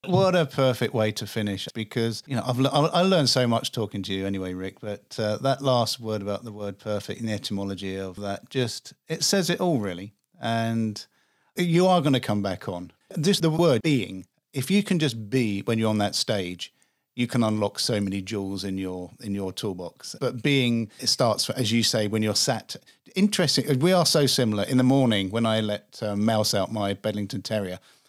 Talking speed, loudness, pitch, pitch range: 215 wpm, -25 LUFS, 115 Hz, 100-135 Hz